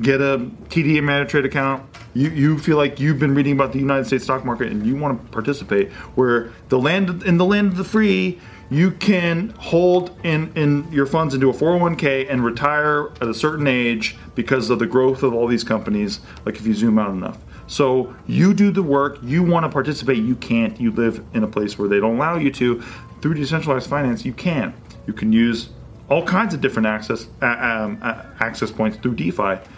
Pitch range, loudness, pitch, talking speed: 120-155 Hz, -19 LUFS, 140 Hz, 210 wpm